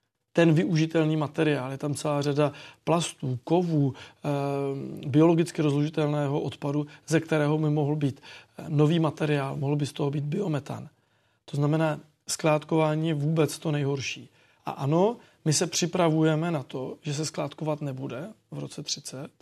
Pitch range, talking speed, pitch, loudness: 140-160 Hz, 140 wpm, 150 Hz, -27 LUFS